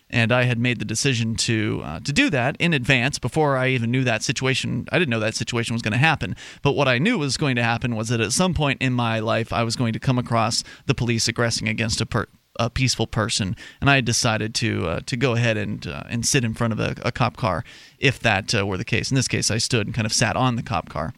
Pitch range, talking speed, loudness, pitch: 115-130 Hz, 280 wpm, -22 LUFS, 120 Hz